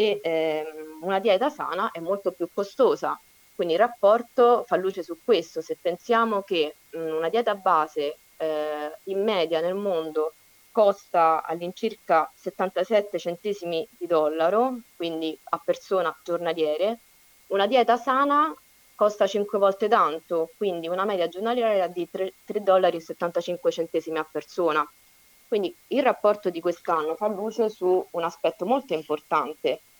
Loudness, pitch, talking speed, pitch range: -25 LUFS, 180 Hz, 135 wpm, 165-210 Hz